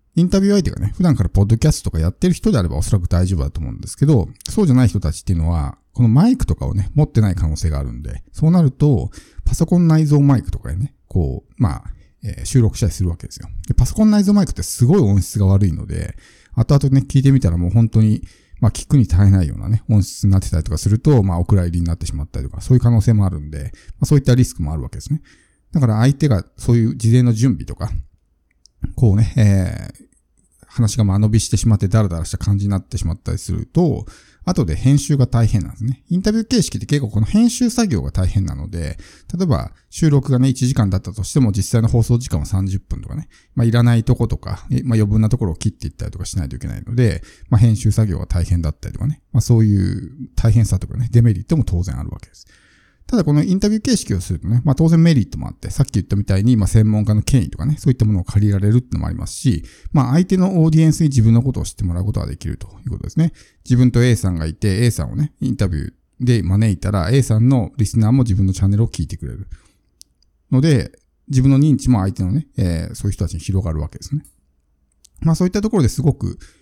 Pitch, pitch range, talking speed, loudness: 110 Hz, 95-130 Hz, 495 characters per minute, -17 LUFS